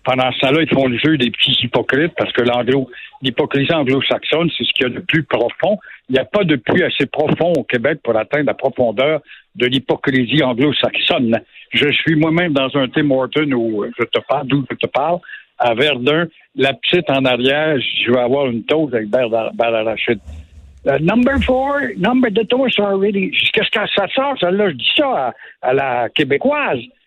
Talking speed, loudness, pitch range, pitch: 195 wpm, -16 LUFS, 125-170 Hz, 140 Hz